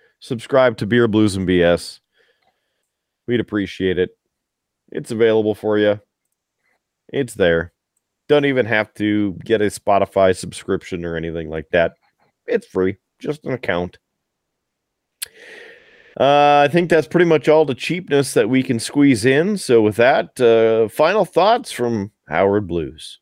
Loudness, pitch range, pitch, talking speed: -17 LUFS, 100-145 Hz, 115 Hz, 140 wpm